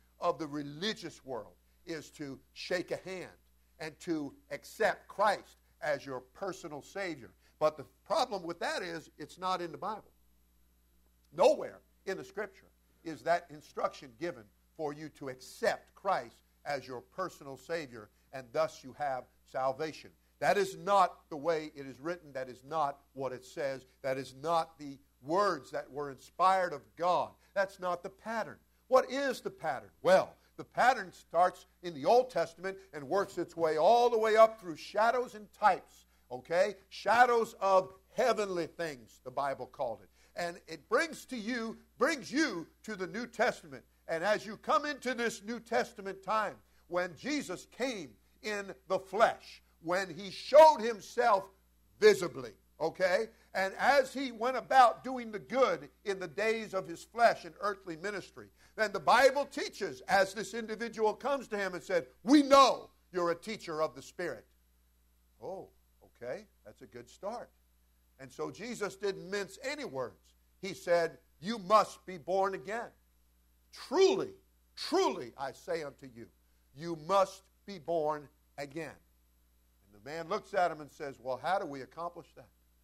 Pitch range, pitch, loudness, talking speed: 135-205 Hz, 170 Hz, -33 LUFS, 165 wpm